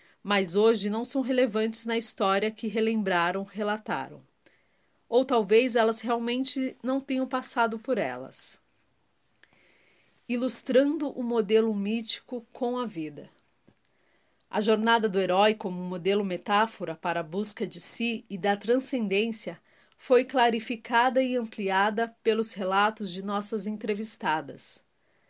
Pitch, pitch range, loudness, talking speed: 225 Hz, 205-240 Hz, -27 LUFS, 125 wpm